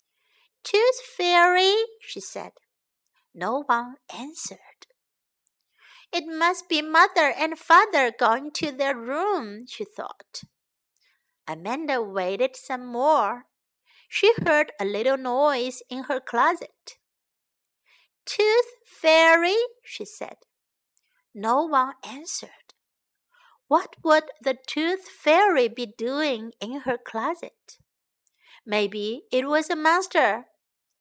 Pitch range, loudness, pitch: 250-365 Hz, -23 LUFS, 300 Hz